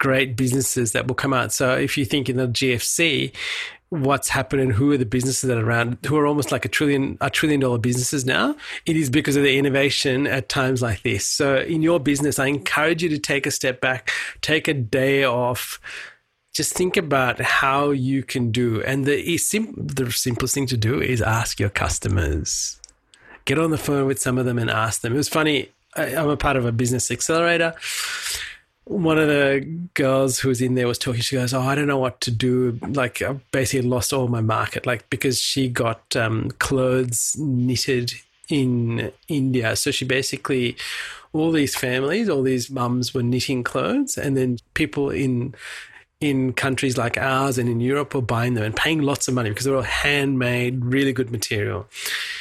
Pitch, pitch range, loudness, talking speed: 130 Hz, 125-140 Hz, -21 LUFS, 200 wpm